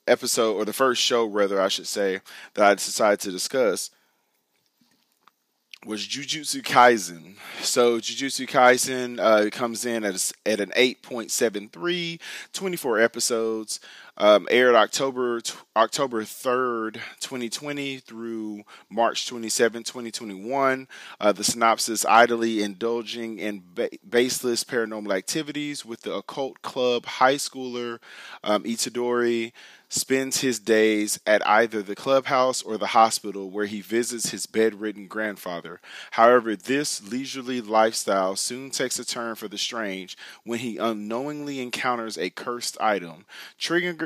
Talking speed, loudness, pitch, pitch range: 130 wpm, -24 LUFS, 115 Hz, 110-130 Hz